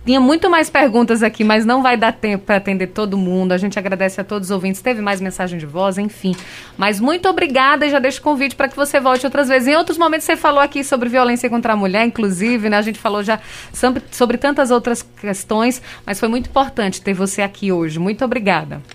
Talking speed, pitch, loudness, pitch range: 230 wpm, 230 Hz, -16 LUFS, 200-270 Hz